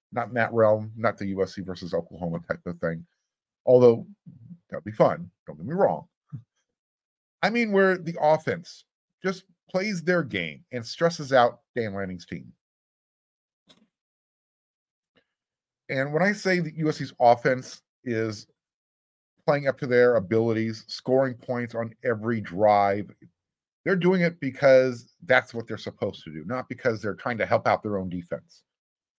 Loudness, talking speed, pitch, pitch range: -25 LUFS, 150 wpm, 120 Hz, 105-155 Hz